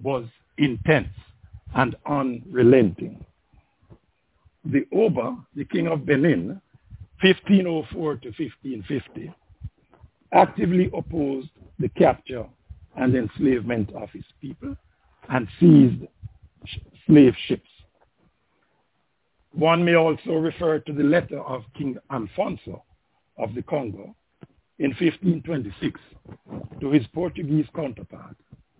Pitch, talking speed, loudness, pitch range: 140 Hz, 95 wpm, -22 LUFS, 110-160 Hz